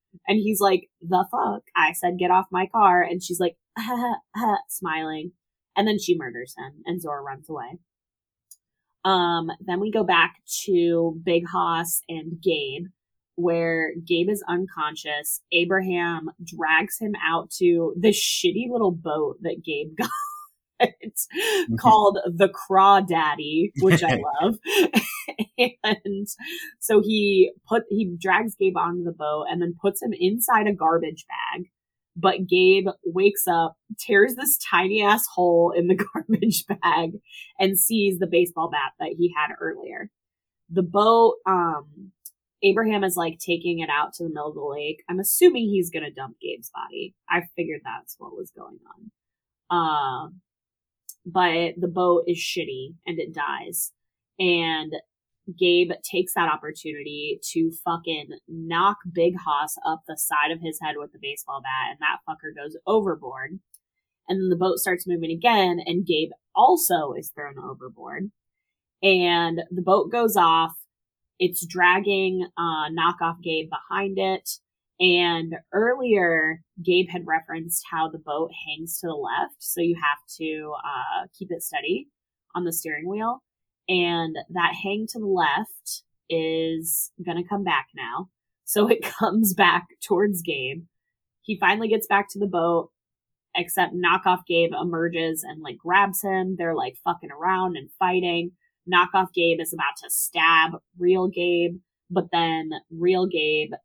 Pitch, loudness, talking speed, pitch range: 175 Hz, -23 LUFS, 150 wpm, 165-200 Hz